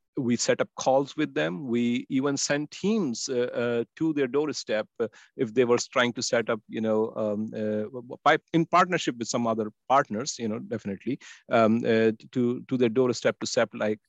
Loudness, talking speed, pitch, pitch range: -27 LUFS, 185 wpm, 120 Hz, 110-135 Hz